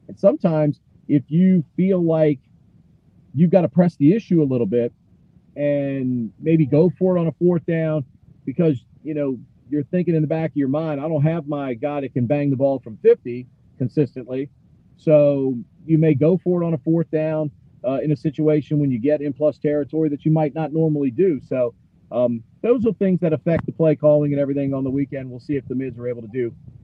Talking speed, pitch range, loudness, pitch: 220 wpm, 135-160 Hz, -20 LUFS, 150 Hz